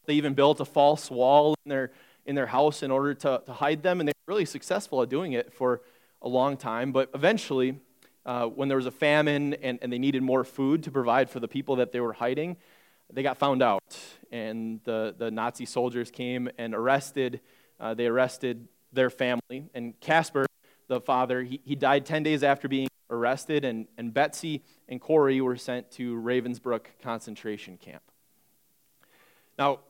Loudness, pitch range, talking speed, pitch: -27 LUFS, 120-140 Hz, 185 wpm, 130 Hz